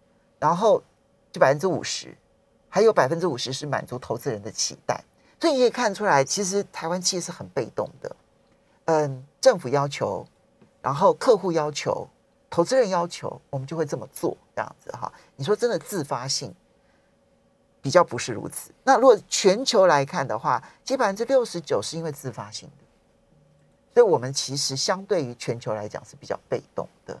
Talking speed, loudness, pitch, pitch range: 275 characters per minute, -24 LUFS, 165 Hz, 135-210 Hz